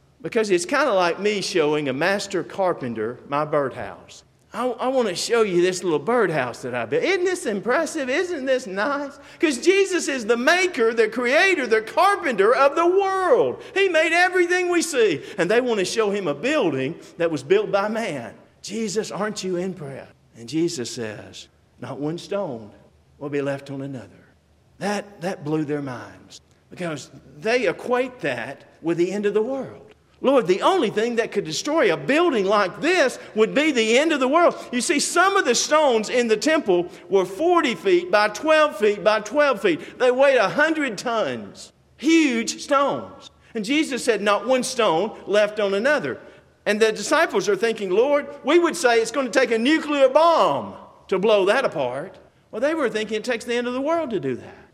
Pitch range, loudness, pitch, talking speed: 185-300 Hz, -21 LUFS, 230 Hz, 195 wpm